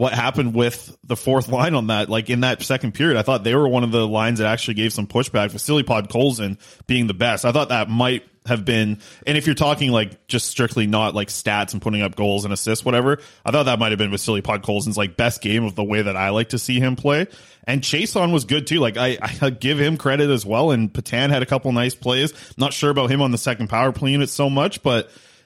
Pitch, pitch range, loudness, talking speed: 120 Hz, 110-140 Hz, -20 LUFS, 265 wpm